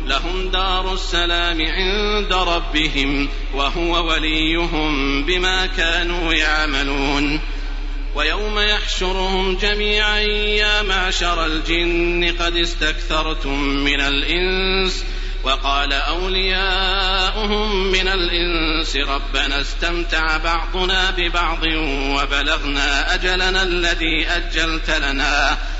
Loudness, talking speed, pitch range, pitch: -18 LUFS, 75 wpm, 150-185 Hz, 170 Hz